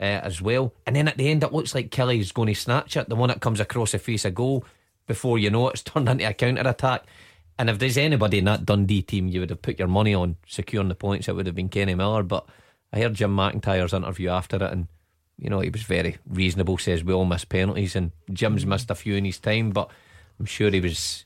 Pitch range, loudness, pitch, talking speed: 95-115 Hz, -24 LUFS, 100 Hz, 255 wpm